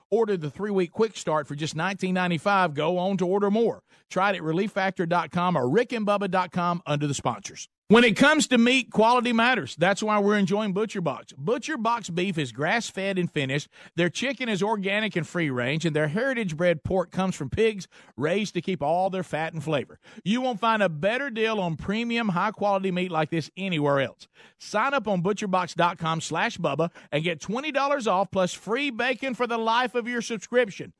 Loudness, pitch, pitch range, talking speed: -25 LUFS, 195 Hz, 170-225 Hz, 185 wpm